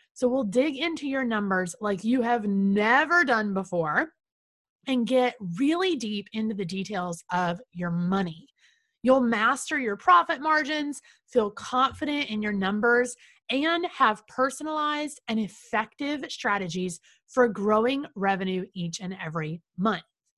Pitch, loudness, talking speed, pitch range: 225 Hz, -26 LUFS, 135 wpm, 190-275 Hz